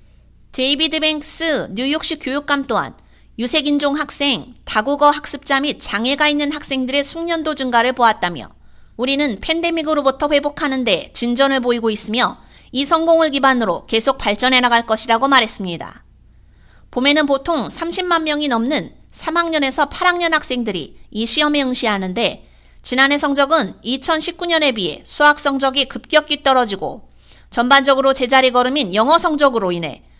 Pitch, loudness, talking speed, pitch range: 275 Hz, -16 LUFS, 325 characters per minute, 245-300 Hz